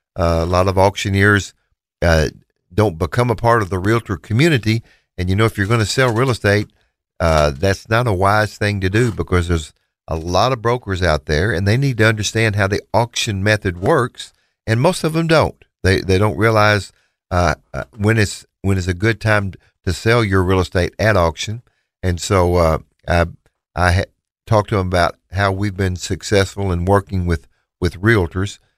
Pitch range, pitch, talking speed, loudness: 90-110 Hz, 100 Hz, 195 wpm, -17 LUFS